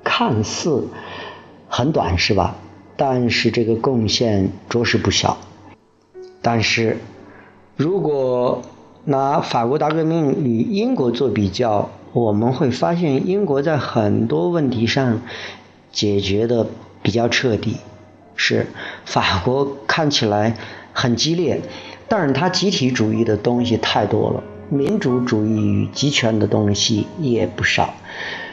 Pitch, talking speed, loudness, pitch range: 120 Hz, 185 characters per minute, -19 LUFS, 105-140 Hz